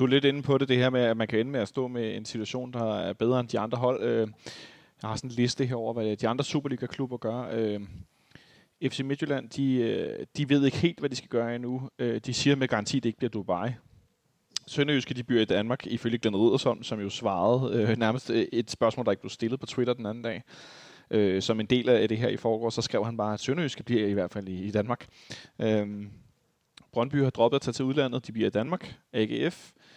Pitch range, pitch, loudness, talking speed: 110-130 Hz, 120 Hz, -28 LUFS, 225 wpm